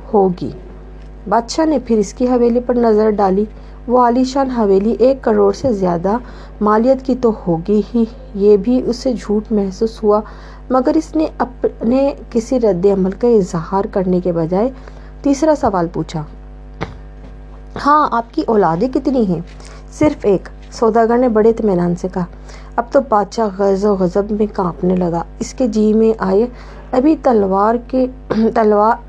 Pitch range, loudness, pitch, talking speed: 200-250 Hz, -15 LUFS, 220 Hz, 155 wpm